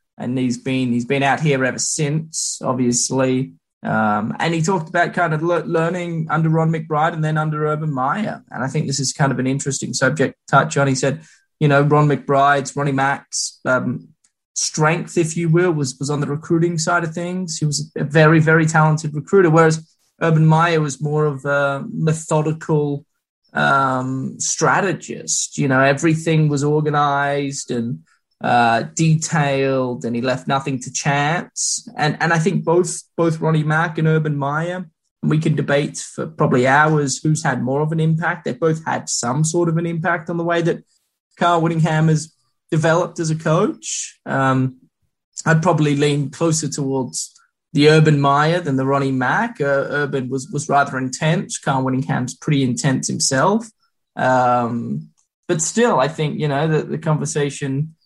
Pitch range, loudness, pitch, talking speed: 135-160 Hz, -18 LUFS, 150 Hz, 175 wpm